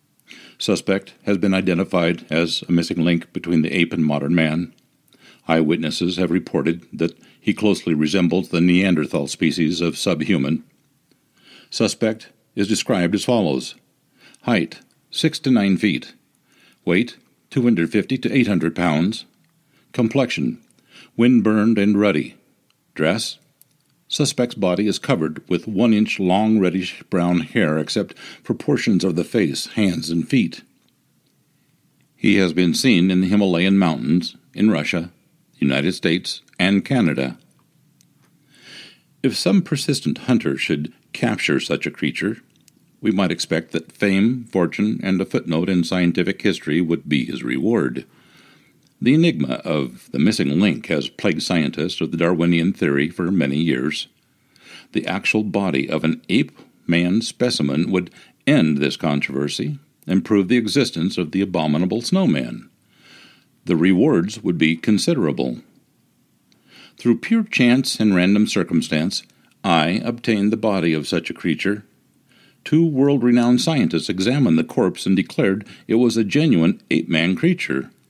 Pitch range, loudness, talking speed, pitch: 85-120 Hz, -19 LUFS, 135 wpm, 95 Hz